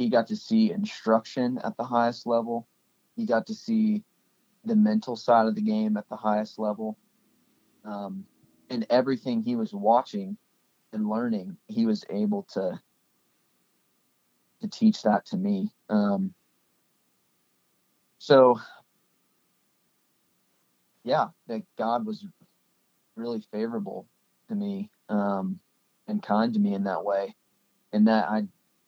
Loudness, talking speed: -27 LUFS, 125 wpm